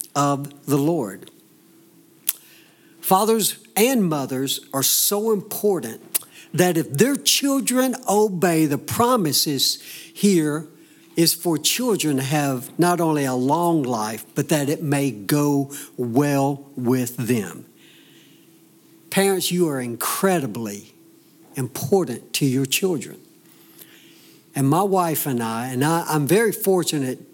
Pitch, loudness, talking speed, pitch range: 155 Hz, -21 LUFS, 115 wpm, 135-185 Hz